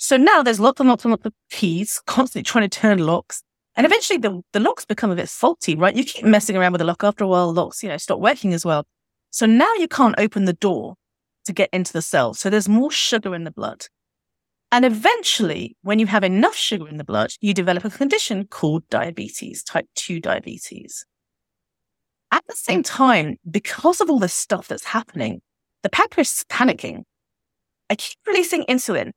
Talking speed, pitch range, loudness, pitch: 205 wpm, 185-255 Hz, -19 LUFS, 210 Hz